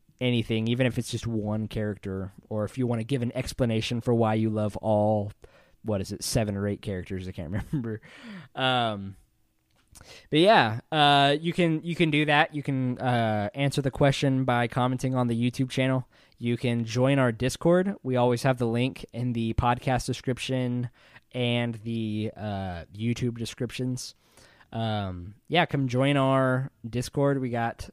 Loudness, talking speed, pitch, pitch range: -27 LUFS, 170 wpm, 120 Hz, 110-130 Hz